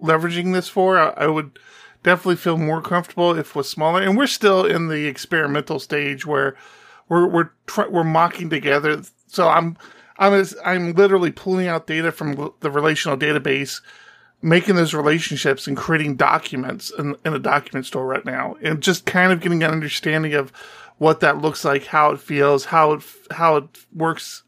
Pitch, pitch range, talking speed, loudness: 160 Hz, 150-175 Hz, 175 wpm, -19 LUFS